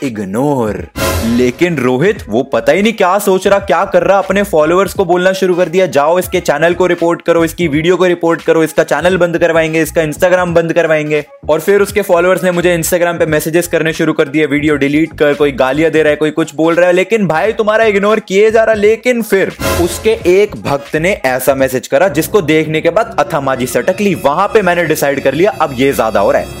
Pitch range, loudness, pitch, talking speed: 150-190 Hz, -11 LUFS, 170 Hz, 225 wpm